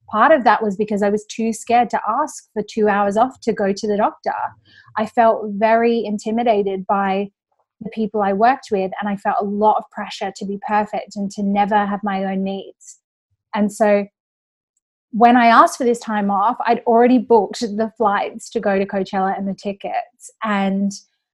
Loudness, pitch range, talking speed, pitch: -18 LUFS, 200-230 Hz, 195 wpm, 210 Hz